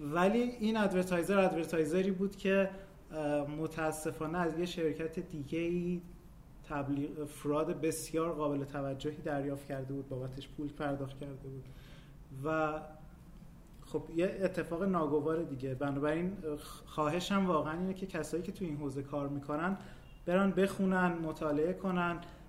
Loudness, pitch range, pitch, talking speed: -35 LUFS, 145-175 Hz, 160 Hz, 125 wpm